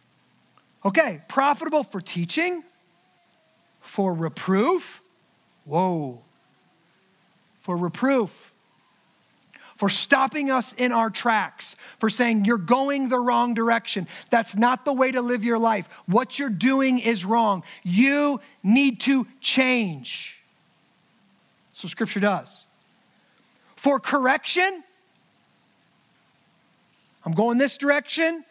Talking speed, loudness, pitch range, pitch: 100 wpm, -23 LUFS, 200-270 Hz, 235 Hz